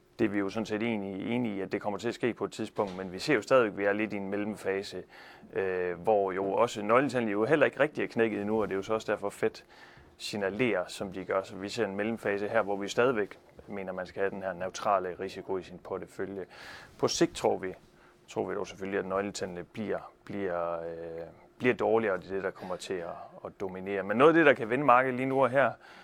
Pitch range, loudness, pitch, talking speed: 95-110 Hz, -30 LUFS, 100 Hz, 255 wpm